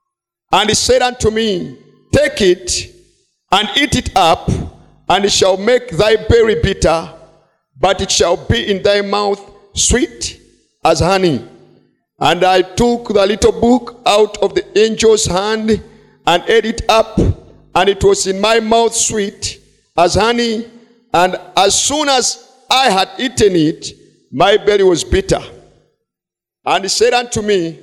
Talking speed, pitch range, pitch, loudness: 150 wpm, 190-245 Hz, 215 Hz, -13 LUFS